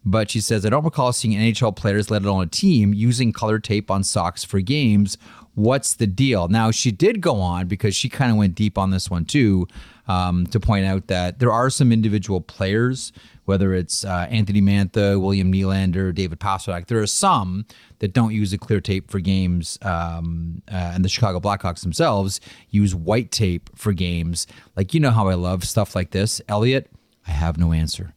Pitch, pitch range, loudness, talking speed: 100 Hz, 95-110 Hz, -20 LUFS, 200 wpm